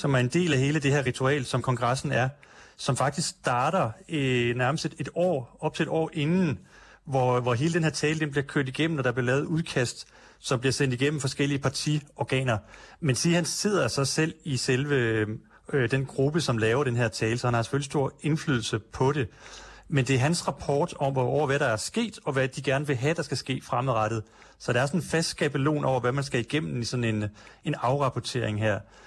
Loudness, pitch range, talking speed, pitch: -27 LUFS, 125-150 Hz, 225 wpm, 135 Hz